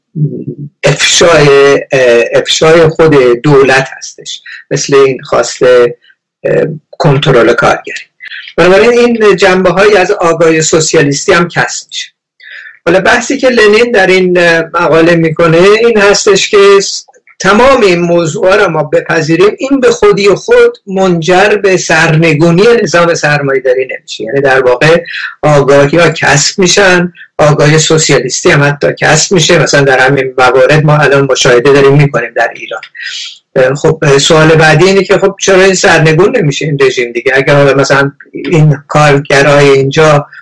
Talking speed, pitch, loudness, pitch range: 135 wpm, 165 Hz, -6 LUFS, 140-195 Hz